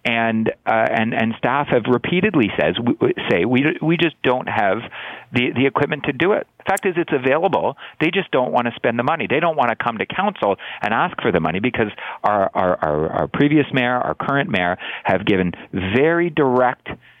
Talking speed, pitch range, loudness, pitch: 210 wpm, 120-160 Hz, -19 LUFS, 135 Hz